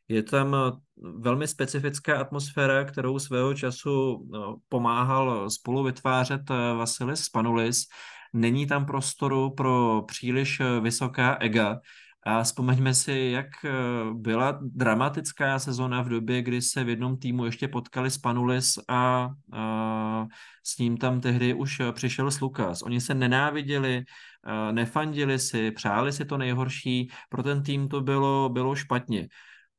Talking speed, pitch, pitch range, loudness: 125 wpm, 130 Hz, 120-135 Hz, -27 LUFS